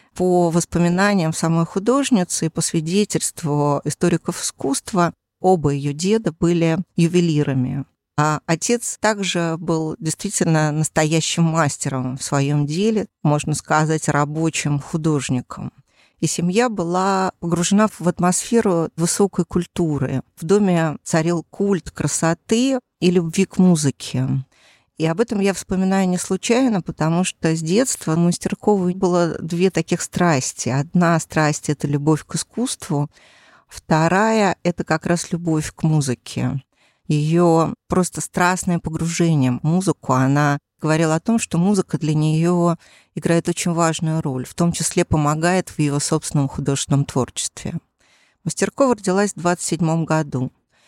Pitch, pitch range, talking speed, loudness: 165 Hz, 150-180 Hz, 125 wpm, -19 LUFS